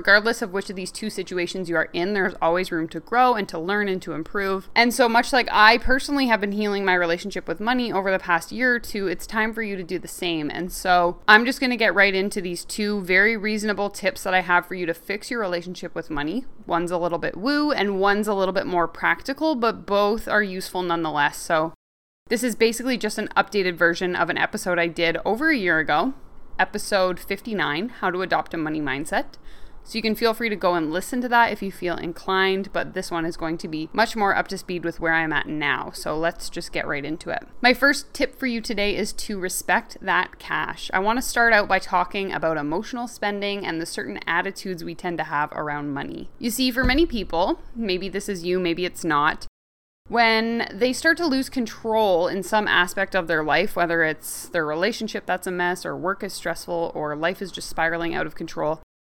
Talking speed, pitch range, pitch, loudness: 230 wpm, 170-220 Hz, 190 Hz, -23 LUFS